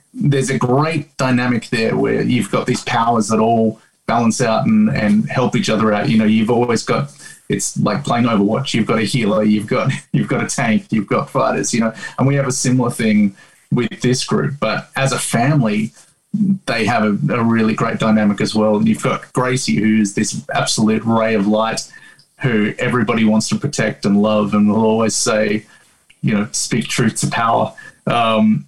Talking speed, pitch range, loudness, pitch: 200 wpm, 110-125 Hz, -16 LUFS, 110 Hz